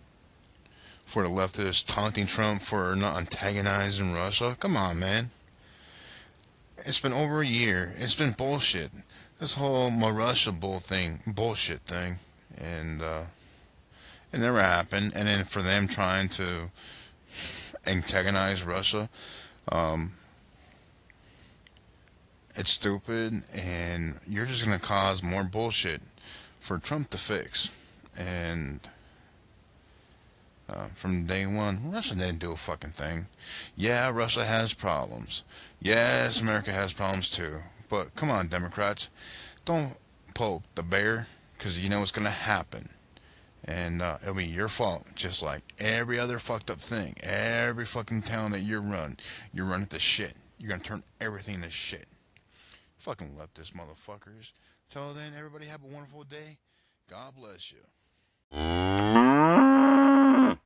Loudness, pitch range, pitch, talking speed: -27 LUFS, 90-115 Hz, 100 Hz, 130 wpm